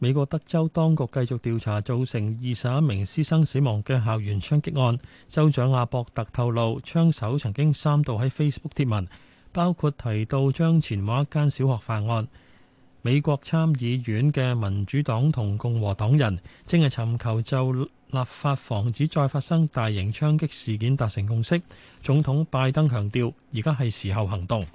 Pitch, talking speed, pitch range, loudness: 130 Hz, 270 characters per minute, 115-145 Hz, -25 LUFS